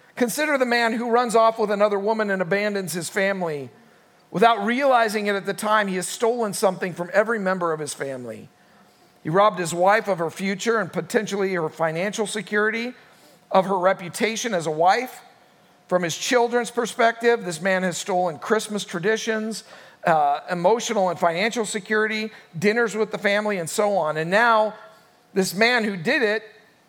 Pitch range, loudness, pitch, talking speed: 185-225 Hz, -22 LUFS, 210 Hz, 170 wpm